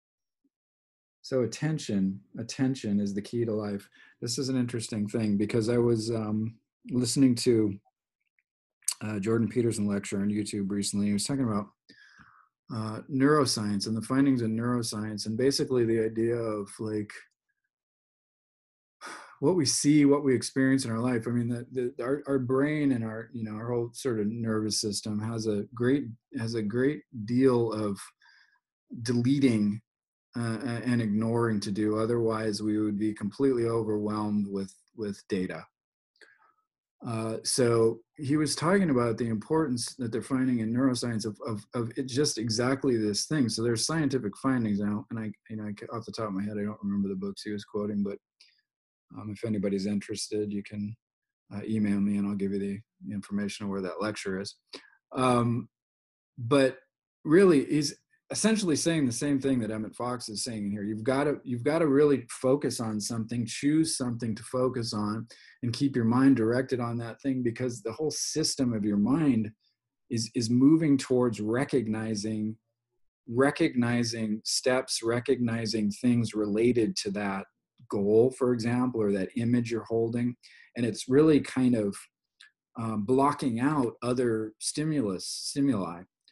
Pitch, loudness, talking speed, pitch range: 115 Hz, -28 LUFS, 160 wpm, 105-130 Hz